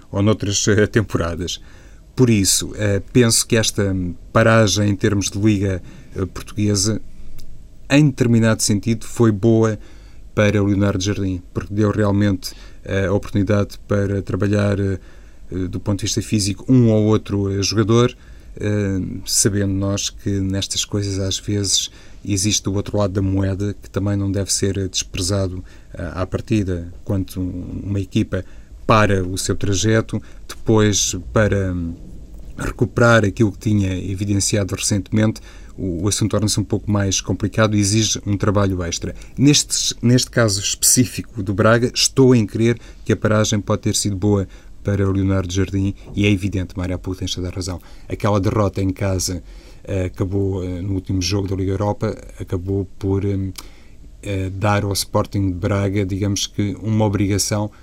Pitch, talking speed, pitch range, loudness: 100 Hz, 145 wpm, 95-105 Hz, -19 LUFS